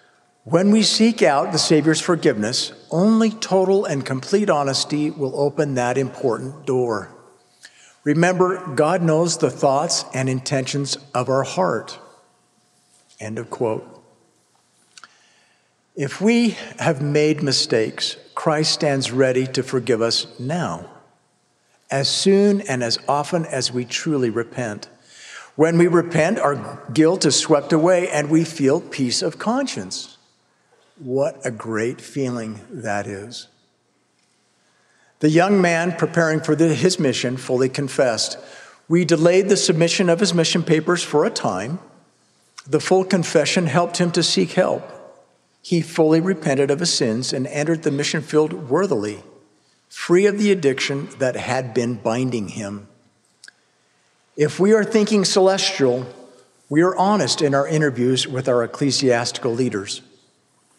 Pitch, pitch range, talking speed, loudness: 150 Hz, 130-175 Hz, 135 wpm, -19 LUFS